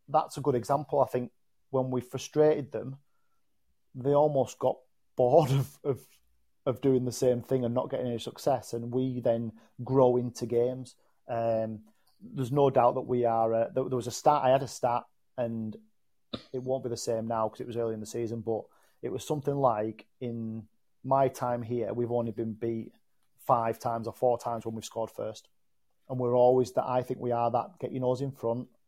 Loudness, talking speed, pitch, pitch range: -30 LUFS, 205 wpm, 125 Hz, 115-130 Hz